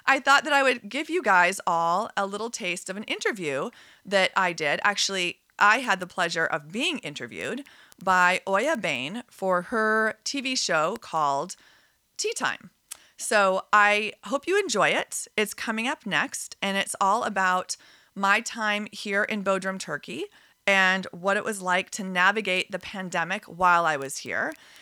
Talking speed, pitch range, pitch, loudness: 165 wpm, 185-230 Hz, 200 Hz, -25 LUFS